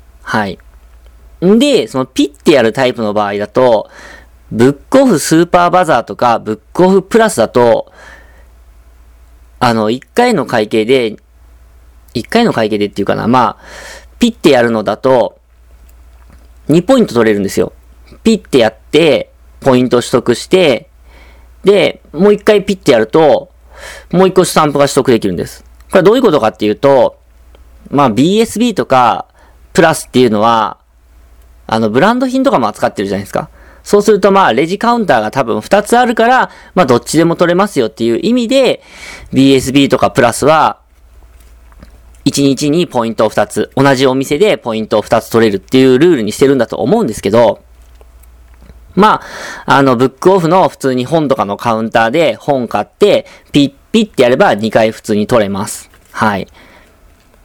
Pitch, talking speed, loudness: 115 Hz, 330 characters per minute, -11 LUFS